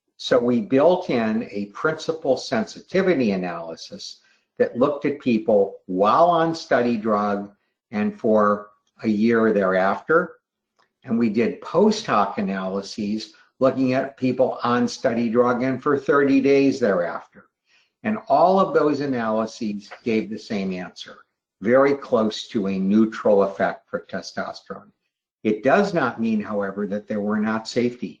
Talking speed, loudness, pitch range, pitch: 140 wpm, -21 LUFS, 105-145 Hz, 120 Hz